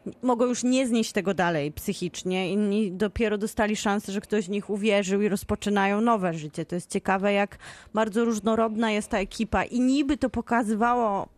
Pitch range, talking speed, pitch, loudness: 200-230 Hz, 175 wpm, 210 Hz, -26 LUFS